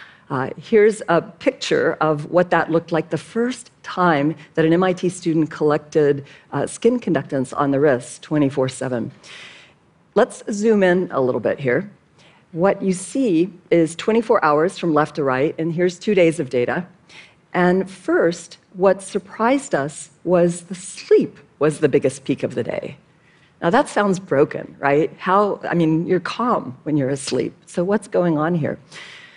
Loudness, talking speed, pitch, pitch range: -20 LUFS, 165 wpm, 170 Hz, 155-190 Hz